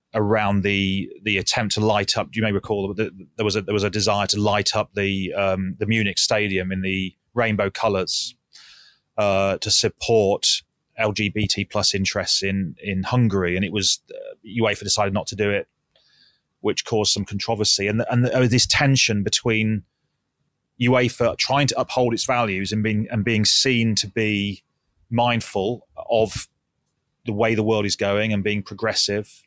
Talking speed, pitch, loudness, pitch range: 175 wpm, 105 Hz, -21 LUFS, 100-115 Hz